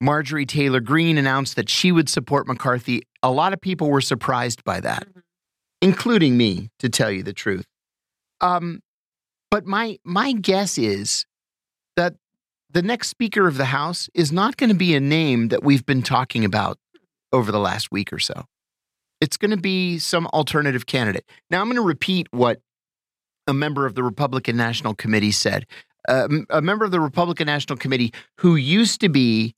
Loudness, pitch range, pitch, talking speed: -20 LUFS, 125-180 Hz, 145 Hz, 180 wpm